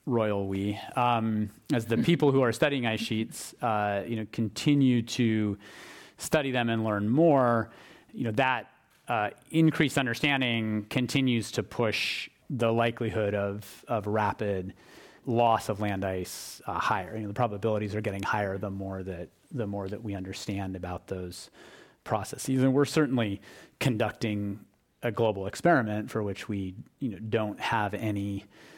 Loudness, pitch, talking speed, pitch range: -29 LUFS, 110 Hz, 155 wpm, 100-120 Hz